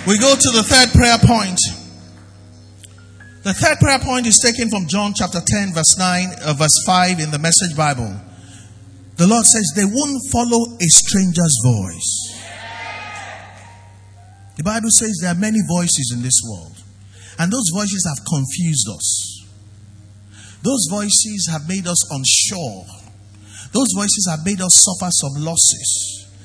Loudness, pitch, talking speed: -14 LUFS, 155 Hz, 145 wpm